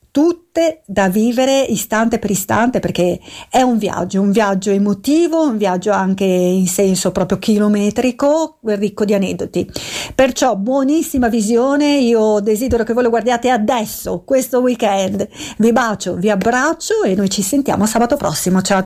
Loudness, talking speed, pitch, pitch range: -15 LUFS, 150 wpm, 220 Hz, 200-260 Hz